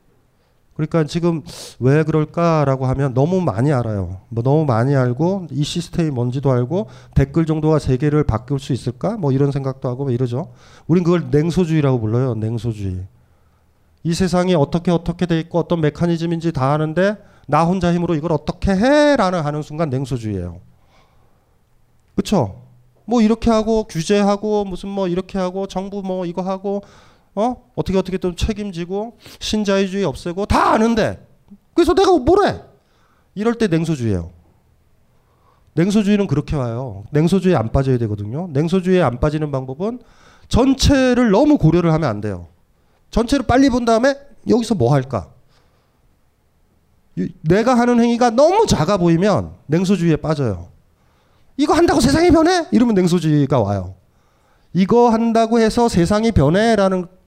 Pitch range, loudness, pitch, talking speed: 130-200 Hz, -17 LUFS, 170 Hz, 330 characters per minute